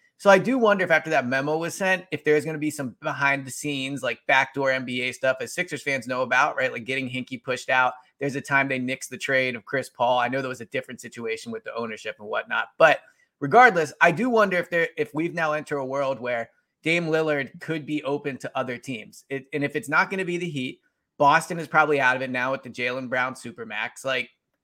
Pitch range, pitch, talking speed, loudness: 130-160 Hz, 140 Hz, 245 wpm, -24 LUFS